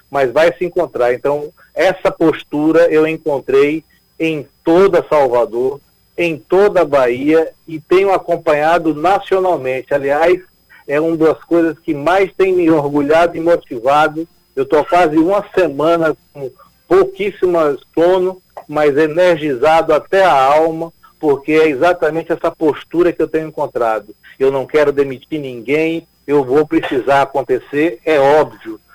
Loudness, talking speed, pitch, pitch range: -14 LUFS, 135 wpm, 160 Hz, 150-175 Hz